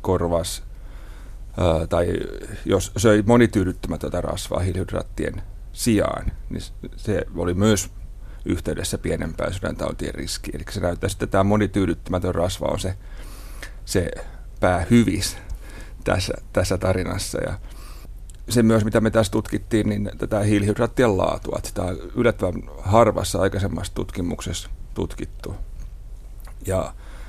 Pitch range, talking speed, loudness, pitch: 90-105 Hz, 110 wpm, -23 LUFS, 95 Hz